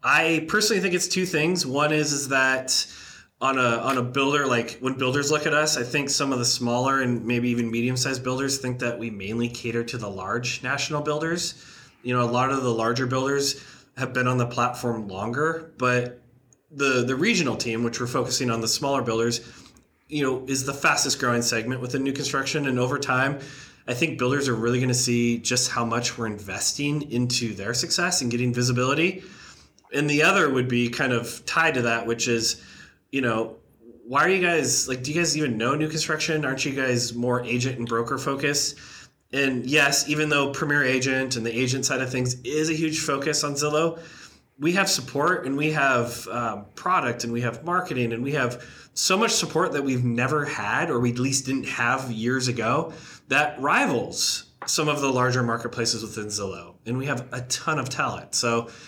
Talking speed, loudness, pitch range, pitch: 205 wpm, -24 LUFS, 120-145 Hz, 130 Hz